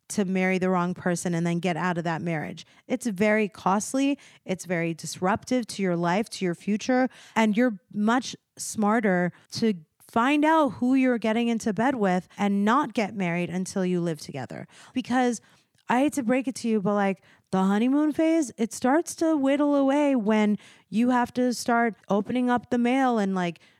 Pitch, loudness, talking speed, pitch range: 215 Hz, -25 LUFS, 185 wpm, 185-250 Hz